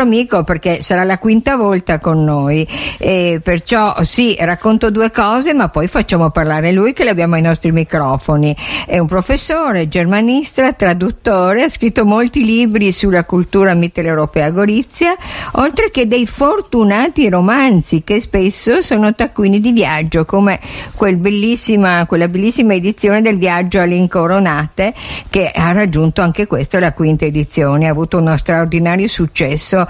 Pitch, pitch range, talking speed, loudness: 185 Hz, 170-220 Hz, 145 wpm, -12 LUFS